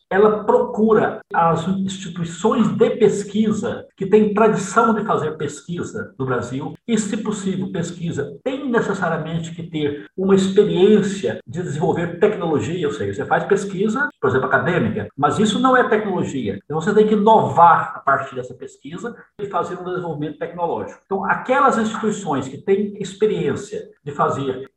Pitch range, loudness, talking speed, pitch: 170-220 Hz, -19 LUFS, 150 wpm, 200 Hz